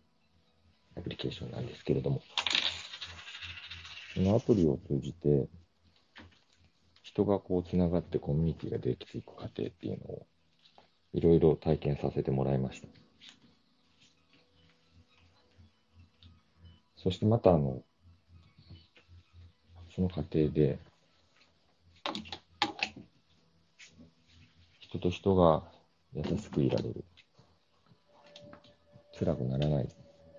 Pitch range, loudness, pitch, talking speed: 75-85 Hz, -32 LUFS, 85 Hz, 195 characters per minute